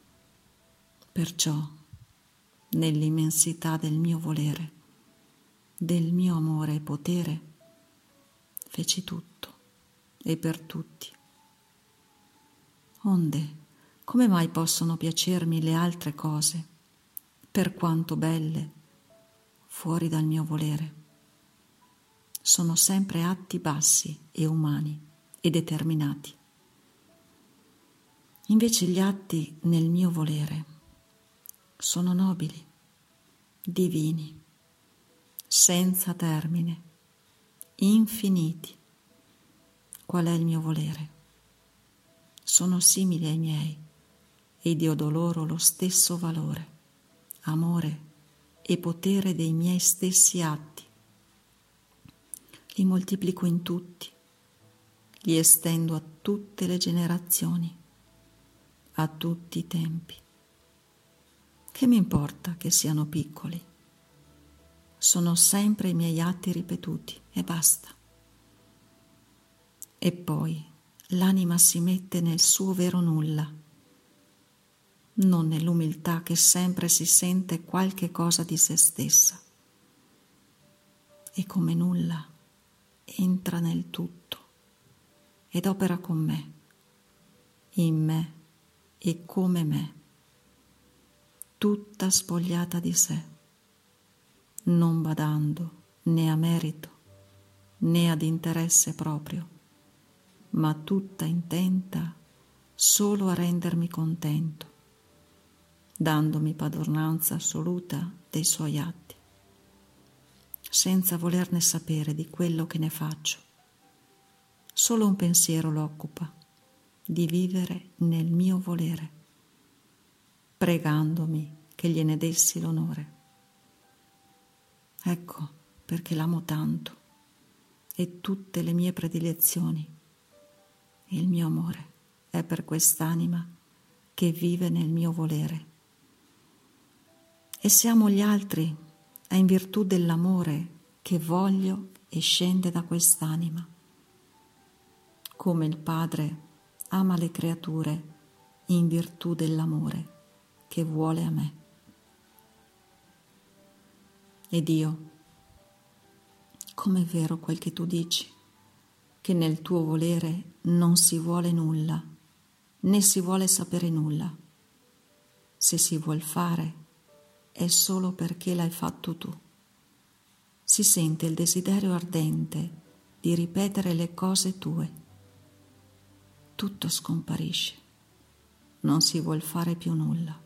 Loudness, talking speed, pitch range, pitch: -26 LUFS, 95 wpm, 155-175 Hz, 165 Hz